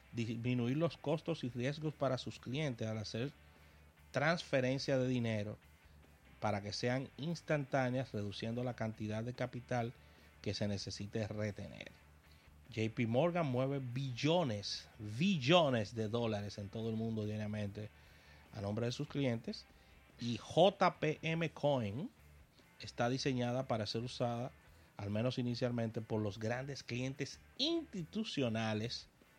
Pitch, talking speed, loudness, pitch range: 120 Hz, 120 wpm, -38 LUFS, 105-135 Hz